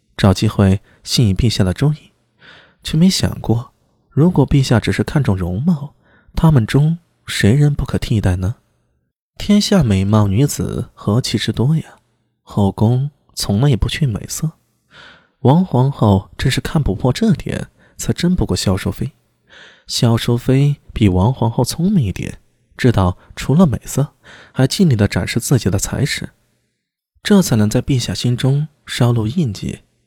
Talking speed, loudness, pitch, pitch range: 220 characters per minute, -16 LUFS, 120 Hz, 100-145 Hz